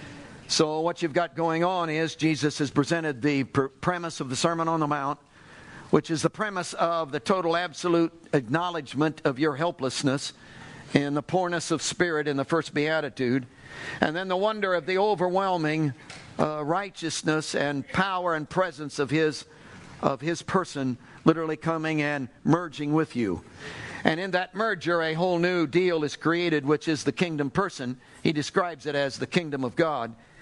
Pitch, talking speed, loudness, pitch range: 160 Hz, 170 wpm, -27 LUFS, 145-175 Hz